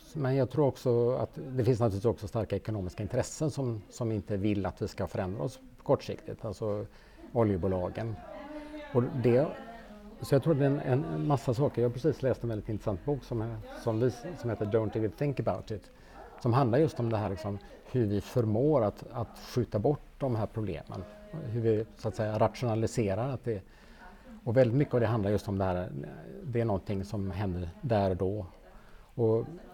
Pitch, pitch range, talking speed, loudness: 115 Hz, 105-135 Hz, 200 wpm, -31 LUFS